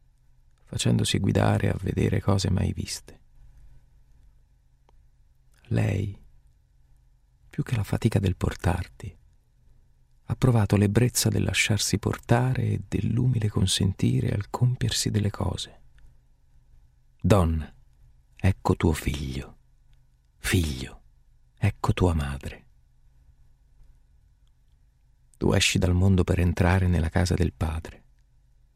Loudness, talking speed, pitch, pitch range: -25 LUFS, 95 wpm, 90 Hz, 65-100 Hz